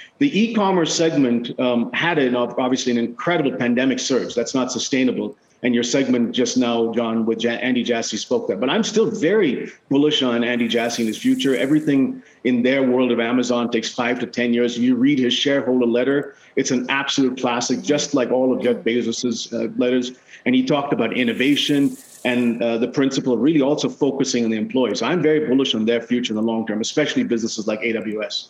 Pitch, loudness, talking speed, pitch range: 125 Hz, -20 LUFS, 205 wpm, 120-140 Hz